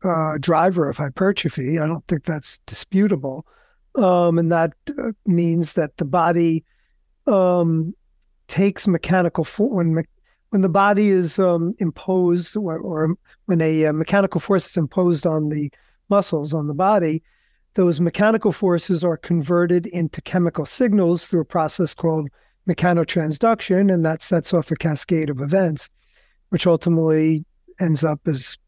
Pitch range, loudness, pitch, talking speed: 160-185 Hz, -20 LUFS, 170 Hz, 145 wpm